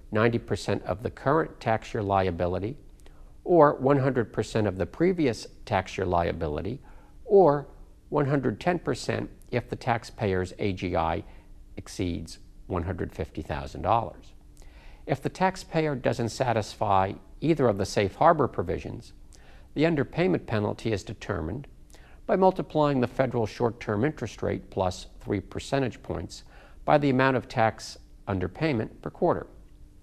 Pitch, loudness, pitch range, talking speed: 110 Hz, -27 LUFS, 90-135 Hz, 120 wpm